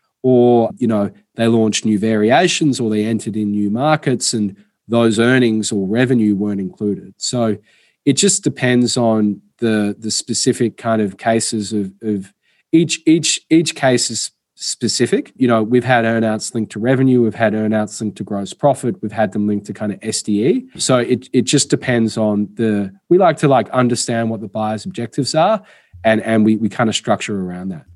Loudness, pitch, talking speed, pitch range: -16 LUFS, 115 Hz, 190 wpm, 105-125 Hz